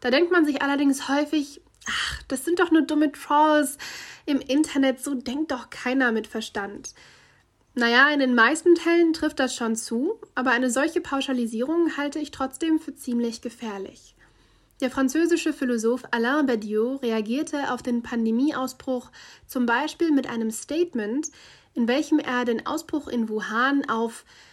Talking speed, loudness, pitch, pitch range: 155 wpm, -24 LUFS, 270 Hz, 240-300 Hz